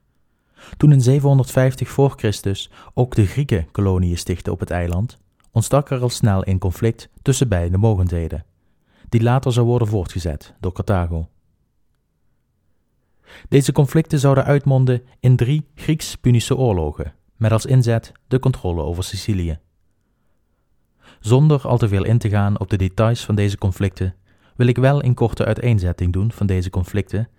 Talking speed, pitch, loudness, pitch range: 145 wpm, 110 Hz, -19 LUFS, 95-125 Hz